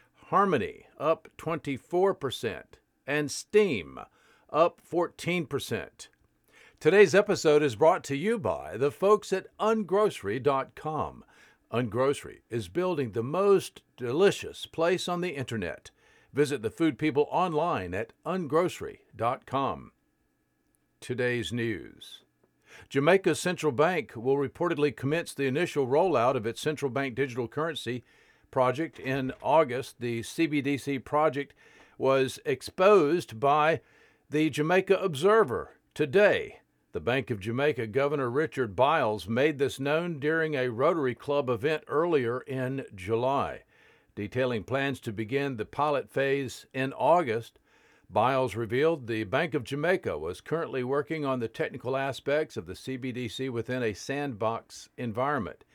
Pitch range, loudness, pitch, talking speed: 125-160 Hz, -28 LUFS, 140 Hz, 120 wpm